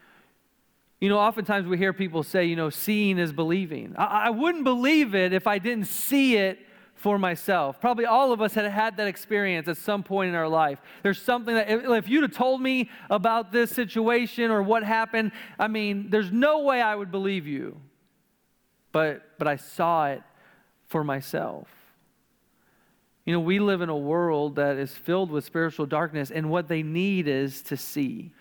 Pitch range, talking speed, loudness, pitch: 165-225 Hz, 190 wpm, -25 LUFS, 200 Hz